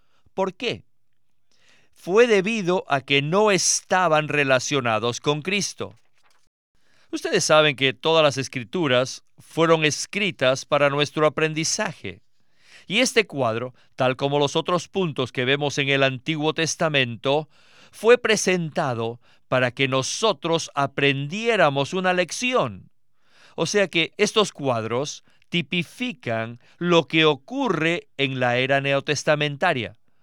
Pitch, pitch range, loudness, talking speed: 150 Hz, 135-180 Hz, -22 LUFS, 115 wpm